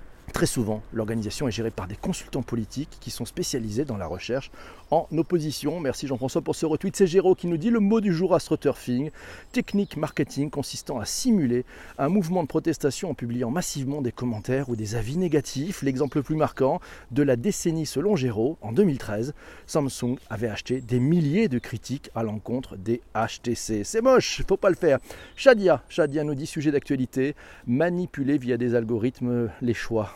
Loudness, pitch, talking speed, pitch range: -26 LUFS, 140 Hz, 180 wpm, 120-165 Hz